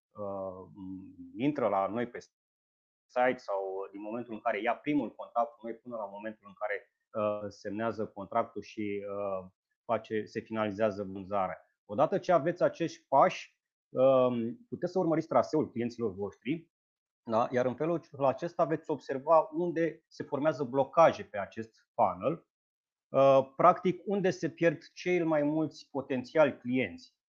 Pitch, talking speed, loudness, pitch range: 125 Hz, 145 wpm, -31 LUFS, 105-160 Hz